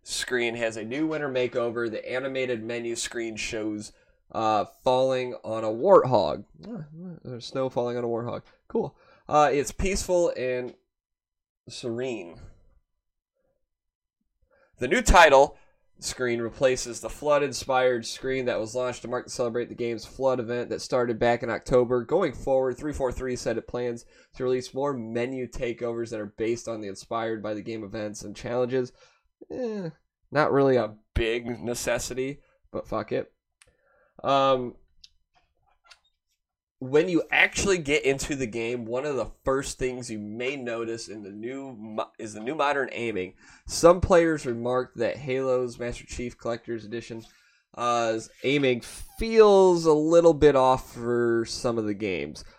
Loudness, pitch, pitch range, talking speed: -26 LUFS, 120 Hz, 115-130 Hz, 150 wpm